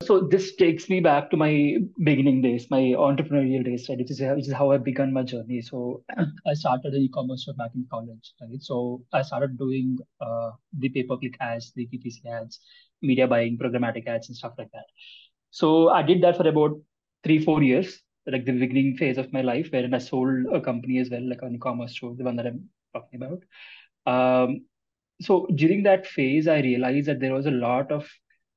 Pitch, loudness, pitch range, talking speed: 130 Hz, -24 LUFS, 125-150 Hz, 205 wpm